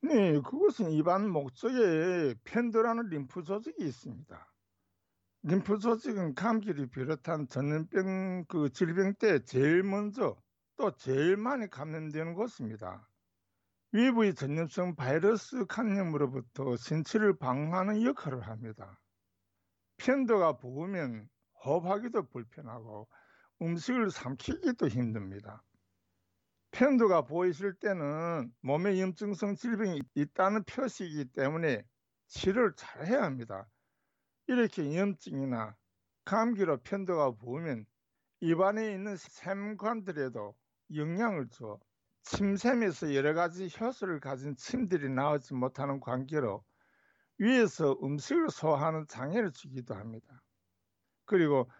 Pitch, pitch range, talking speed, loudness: 155 Hz, 125-200 Hz, 260 characters per minute, -32 LUFS